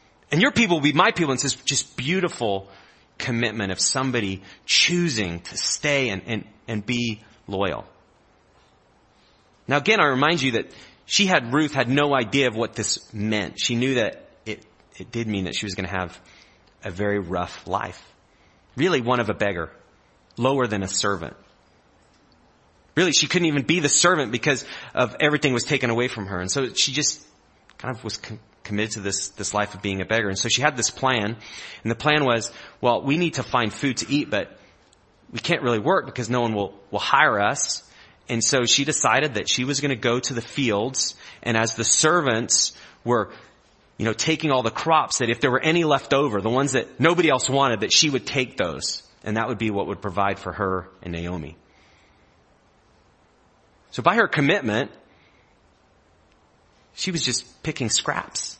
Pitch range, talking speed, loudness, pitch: 100-140 Hz, 195 wpm, -22 LUFS, 115 Hz